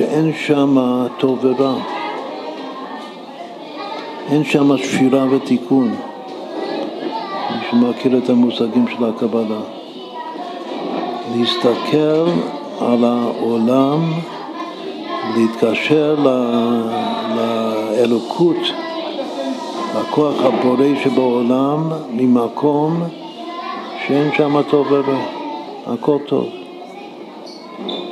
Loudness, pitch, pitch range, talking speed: -17 LUFS, 135 Hz, 120-155 Hz, 60 wpm